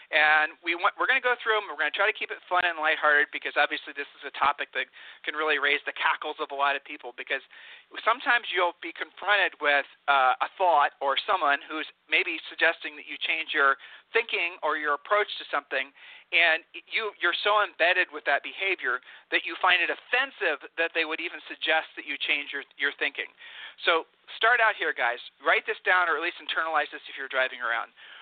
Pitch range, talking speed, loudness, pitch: 150-215 Hz, 215 wpm, -26 LUFS, 170 Hz